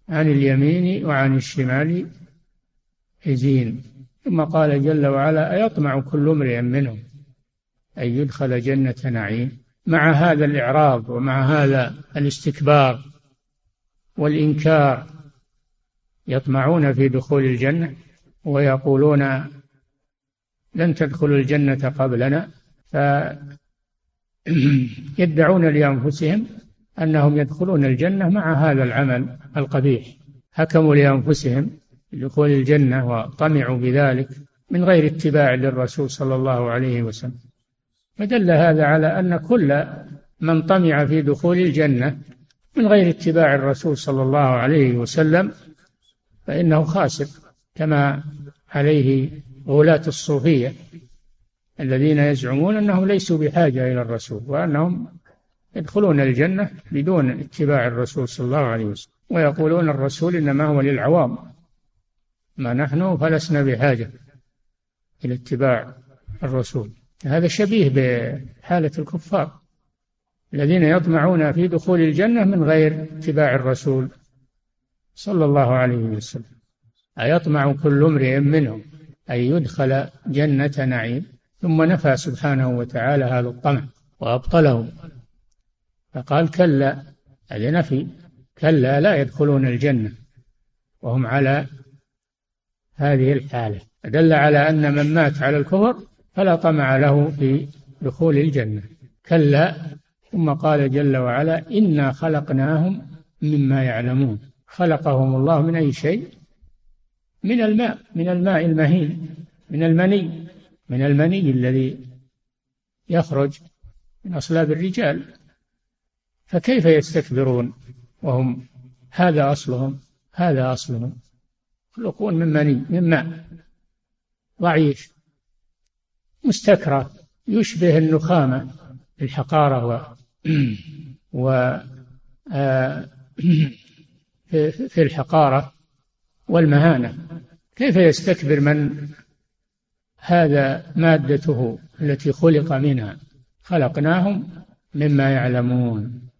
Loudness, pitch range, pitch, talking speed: -19 LUFS, 130-160 Hz, 145 Hz, 95 wpm